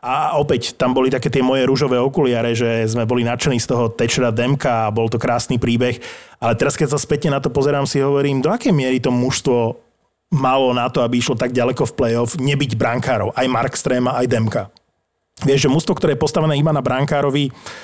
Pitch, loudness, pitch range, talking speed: 130 Hz, -17 LUFS, 120-140 Hz, 210 wpm